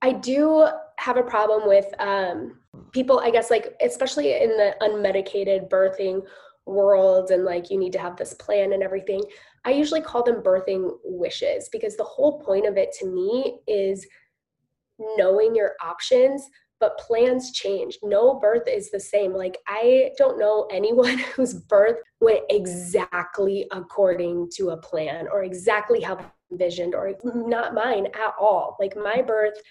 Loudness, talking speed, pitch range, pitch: -22 LUFS, 160 wpm, 195-265 Hz, 215 Hz